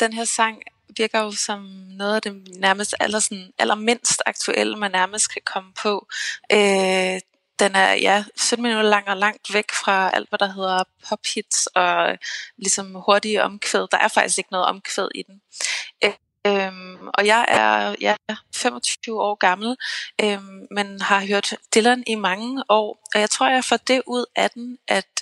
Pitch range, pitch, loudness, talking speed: 195-225 Hz, 205 Hz, -20 LUFS, 175 wpm